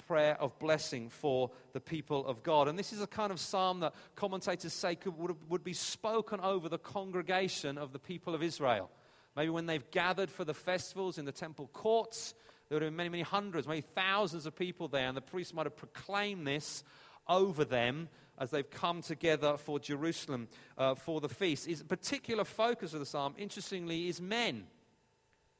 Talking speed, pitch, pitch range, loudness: 190 wpm, 165 Hz, 145-185 Hz, -36 LUFS